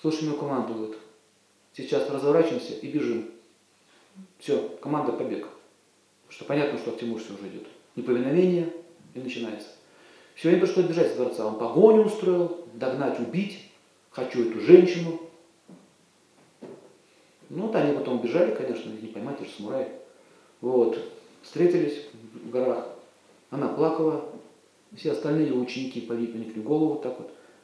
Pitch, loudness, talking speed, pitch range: 150 Hz, -26 LUFS, 135 wpm, 120-175 Hz